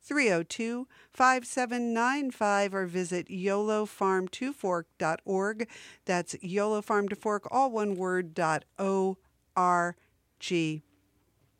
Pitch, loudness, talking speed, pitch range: 195 Hz, -30 LUFS, 105 wpm, 175-225 Hz